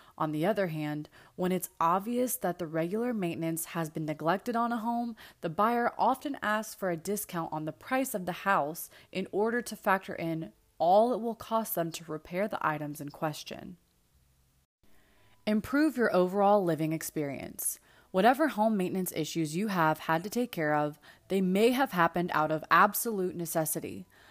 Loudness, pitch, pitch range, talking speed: -30 LUFS, 175 Hz, 155-215 Hz, 175 wpm